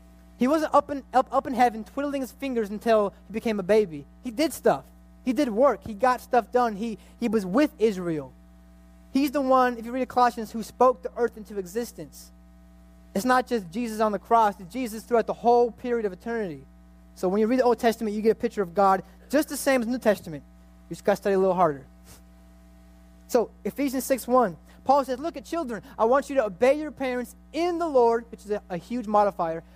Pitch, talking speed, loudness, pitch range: 225 Hz, 225 wpm, -25 LUFS, 185-255 Hz